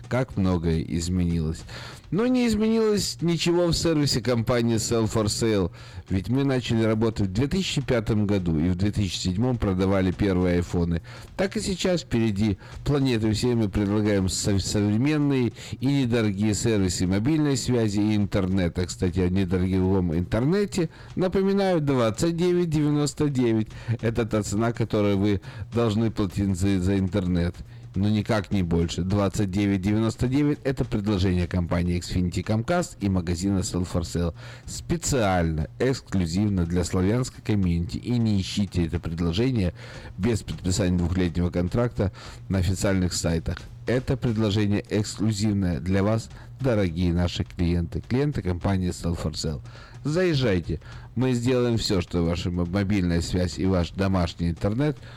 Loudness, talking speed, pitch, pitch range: -25 LUFS, 125 wpm, 105 Hz, 90-125 Hz